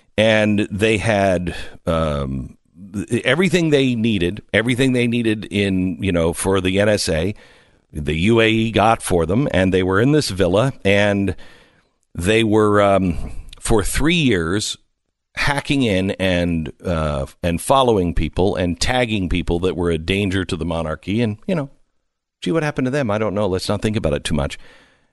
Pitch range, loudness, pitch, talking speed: 85-115 Hz, -18 LUFS, 100 Hz, 165 wpm